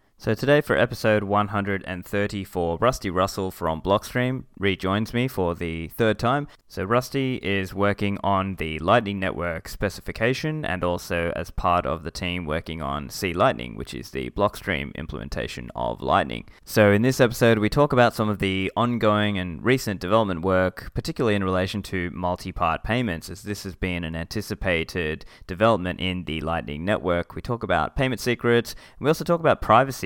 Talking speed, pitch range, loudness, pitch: 170 wpm, 90-115 Hz, -24 LUFS, 100 Hz